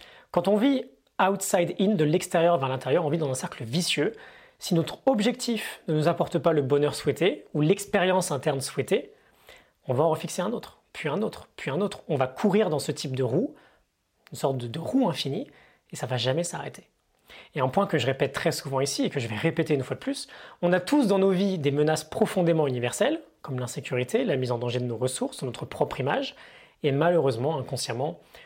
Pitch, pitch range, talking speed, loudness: 160 Hz, 135-190 Hz, 215 wpm, -26 LUFS